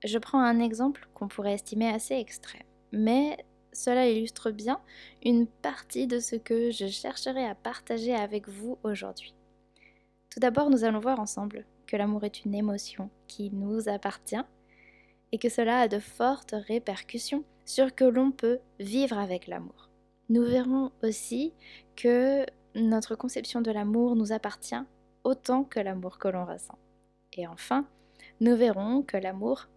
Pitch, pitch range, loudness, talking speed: 235 Hz, 210-255 Hz, -29 LUFS, 150 wpm